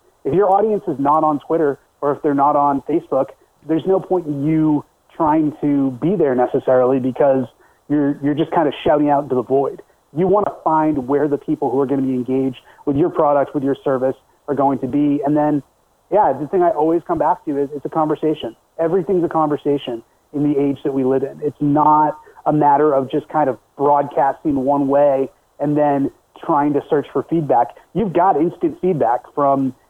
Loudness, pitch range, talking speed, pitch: -18 LUFS, 140-155 Hz, 210 wpm, 145 Hz